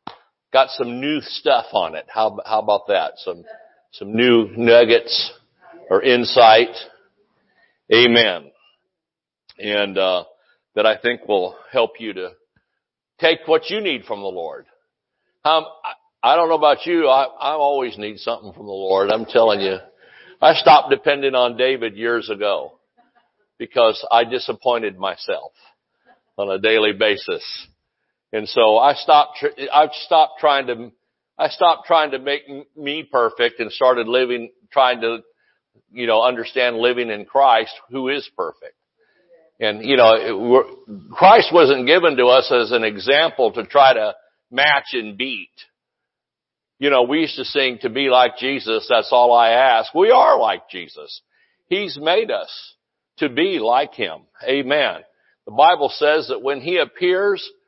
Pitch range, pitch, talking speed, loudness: 120-170 Hz, 135 Hz, 150 wpm, -17 LUFS